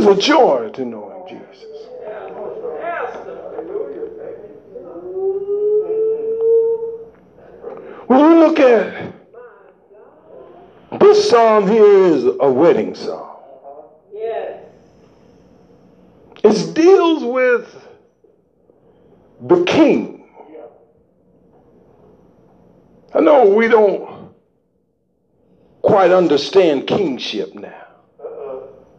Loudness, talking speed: -14 LUFS, 65 wpm